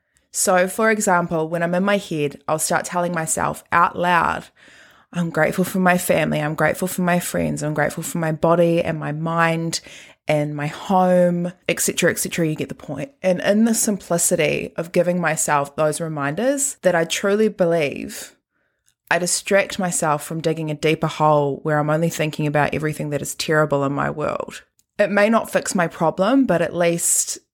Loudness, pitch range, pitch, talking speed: -20 LUFS, 155-185 Hz, 170 Hz, 180 wpm